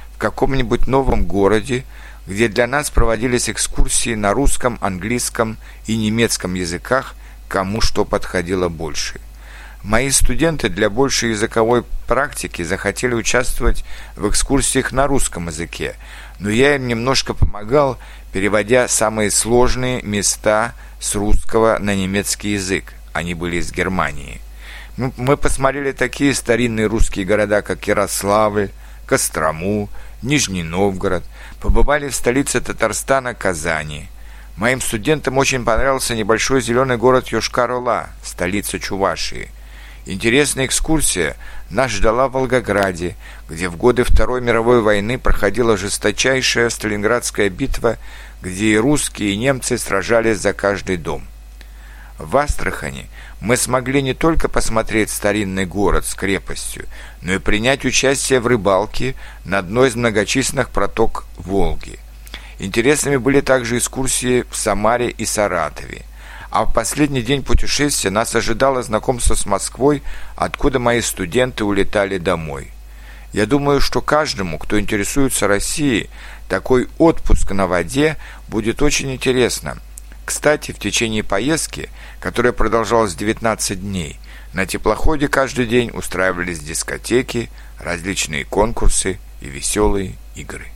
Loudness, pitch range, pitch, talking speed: -18 LUFS, 95-125 Hz, 110 Hz, 120 wpm